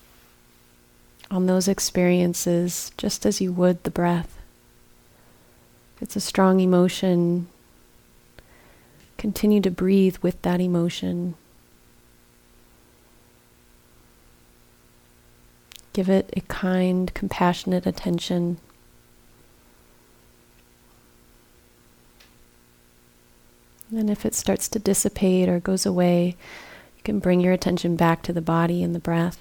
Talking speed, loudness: 100 wpm, -22 LUFS